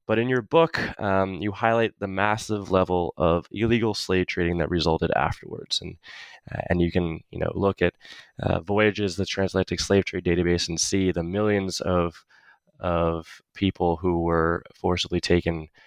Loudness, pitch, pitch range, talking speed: -24 LUFS, 95 Hz, 85-105 Hz, 165 wpm